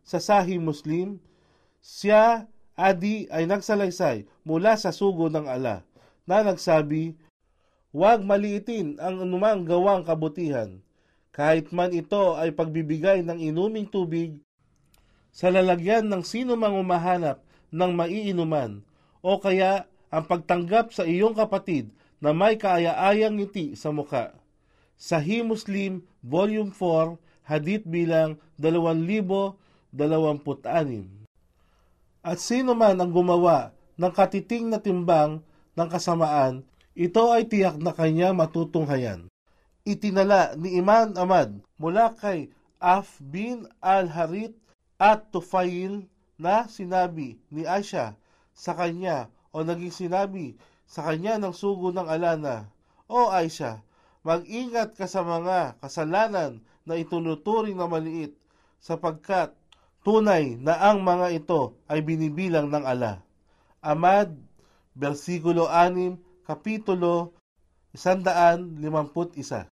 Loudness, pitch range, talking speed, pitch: -24 LUFS, 160-195 Hz, 110 wpm, 175 Hz